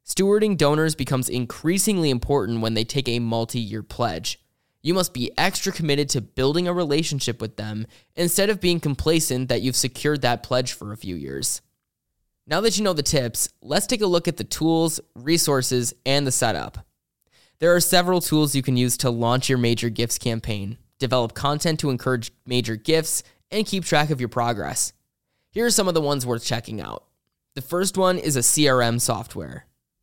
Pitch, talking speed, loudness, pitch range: 130 Hz, 190 wpm, -22 LUFS, 120-165 Hz